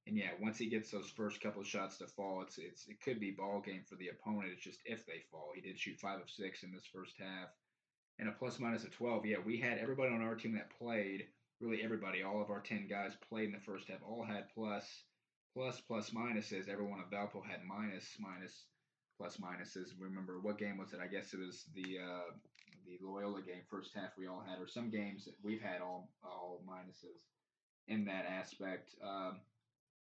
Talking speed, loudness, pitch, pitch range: 220 wpm, -45 LUFS, 100 Hz, 95-110 Hz